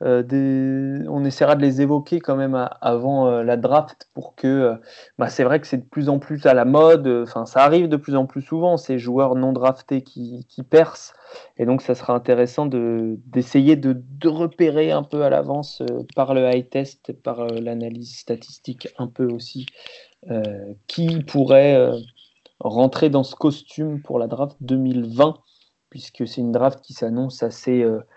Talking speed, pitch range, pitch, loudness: 190 wpm, 120-145 Hz, 130 Hz, -19 LUFS